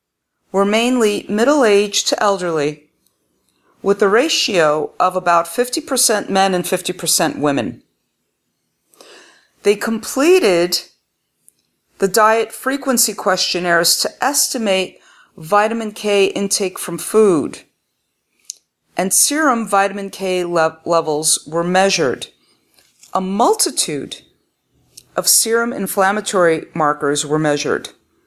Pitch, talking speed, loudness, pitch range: 195 Hz, 95 wpm, -16 LUFS, 170-220 Hz